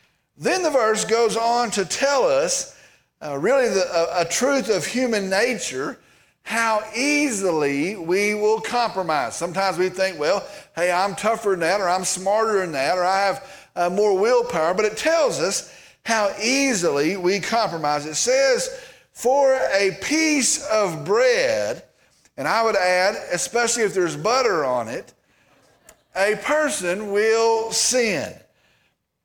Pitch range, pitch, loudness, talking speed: 190-260 Hz, 215 Hz, -21 LUFS, 145 wpm